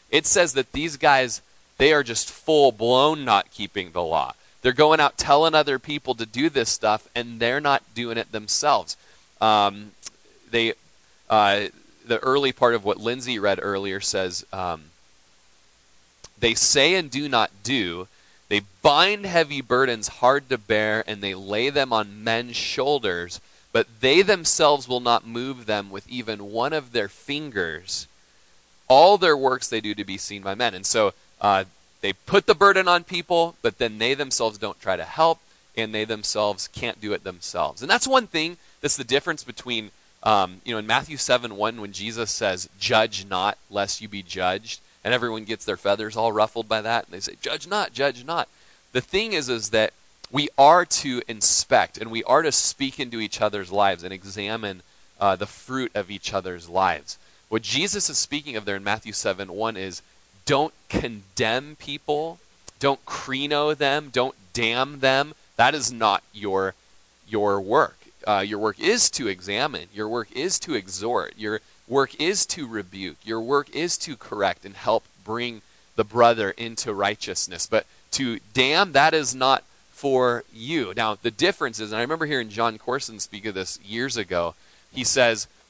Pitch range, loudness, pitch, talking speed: 100-135 Hz, -23 LUFS, 115 Hz, 180 wpm